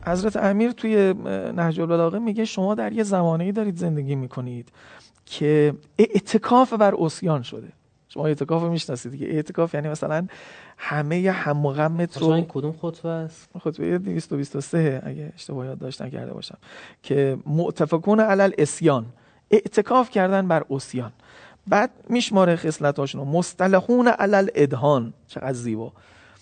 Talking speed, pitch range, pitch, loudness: 130 wpm, 140-195 Hz, 165 Hz, -22 LUFS